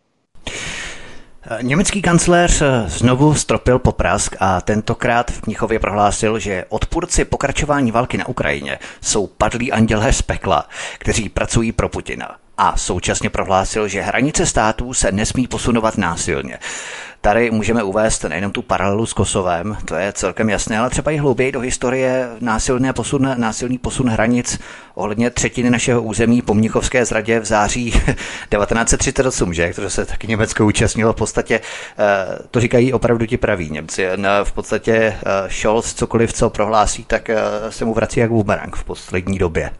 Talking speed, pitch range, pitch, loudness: 145 wpm, 105-120 Hz, 110 Hz, -17 LUFS